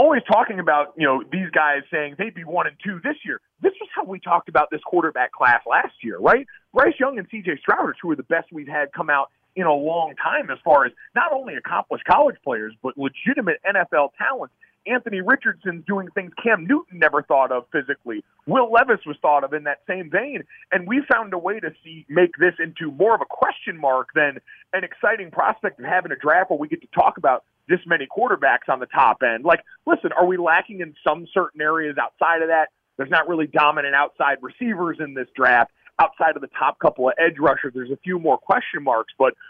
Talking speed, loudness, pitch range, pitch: 225 wpm, -21 LUFS, 150-220 Hz, 175 Hz